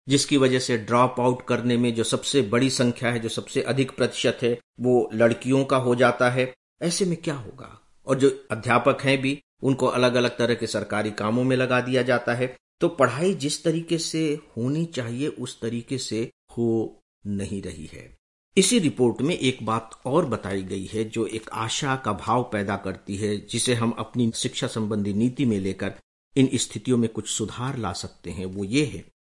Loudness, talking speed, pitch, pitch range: -24 LUFS, 195 wpm, 120 Hz, 110-130 Hz